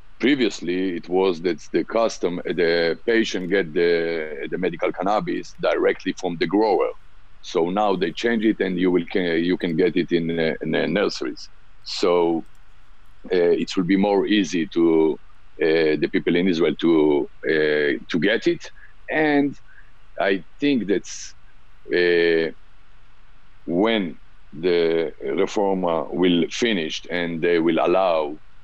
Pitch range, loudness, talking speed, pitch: 85-115 Hz, -21 LUFS, 140 wpm, 90 Hz